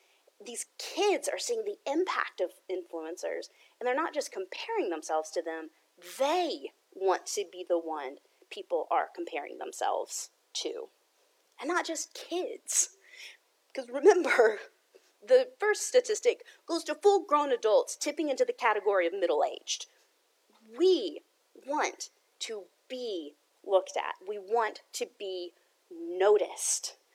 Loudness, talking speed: -31 LUFS, 130 wpm